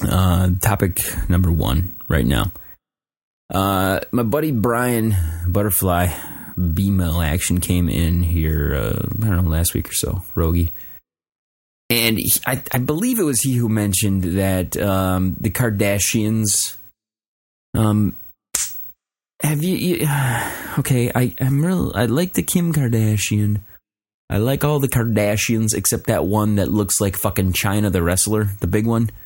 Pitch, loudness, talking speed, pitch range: 105 Hz, -19 LUFS, 145 wpm, 90-115 Hz